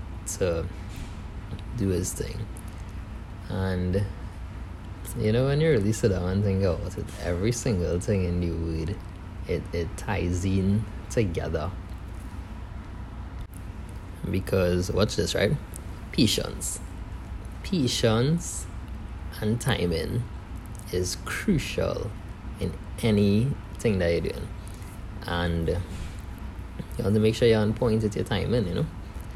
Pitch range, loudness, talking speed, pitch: 90-105 Hz, -27 LUFS, 115 wpm, 95 Hz